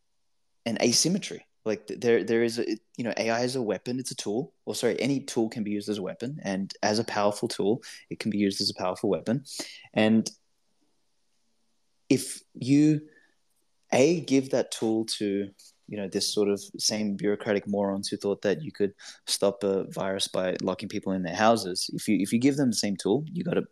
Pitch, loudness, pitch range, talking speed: 105 Hz, -27 LUFS, 100-120 Hz, 205 wpm